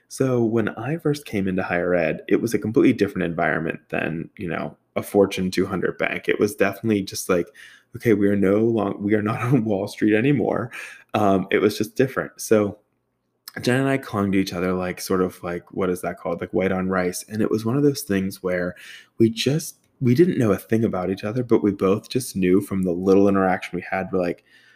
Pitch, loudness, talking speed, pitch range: 100 Hz, -22 LUFS, 230 wpm, 95-115 Hz